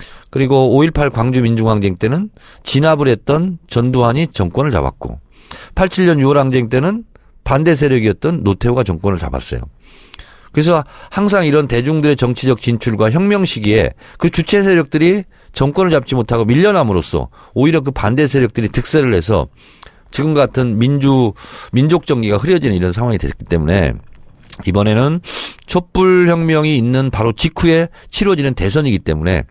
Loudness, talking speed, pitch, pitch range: -14 LUFS, 325 characters per minute, 135 Hz, 110-165 Hz